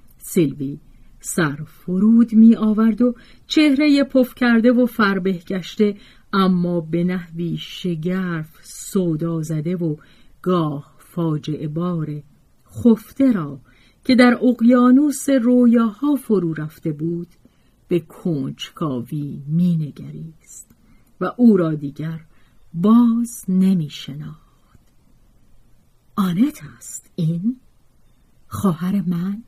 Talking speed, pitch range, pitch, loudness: 95 wpm, 160-230 Hz, 180 Hz, -19 LUFS